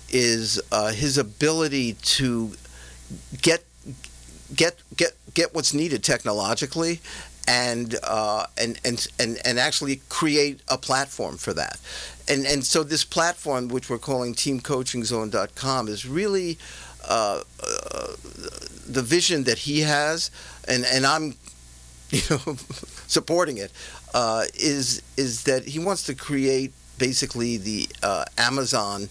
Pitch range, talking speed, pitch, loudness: 115-145 Hz, 125 wpm, 130 Hz, -23 LUFS